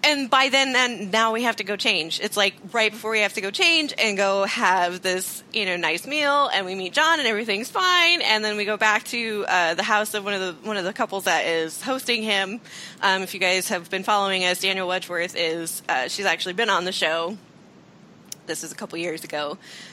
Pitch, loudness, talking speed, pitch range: 205 Hz, -22 LUFS, 245 wpm, 185-225 Hz